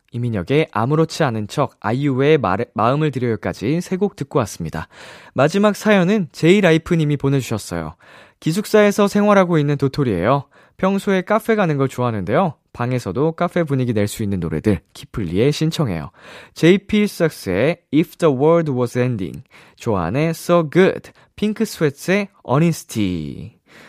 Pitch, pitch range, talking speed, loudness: 150 Hz, 125-175 Hz, 385 characters per minute, -18 LUFS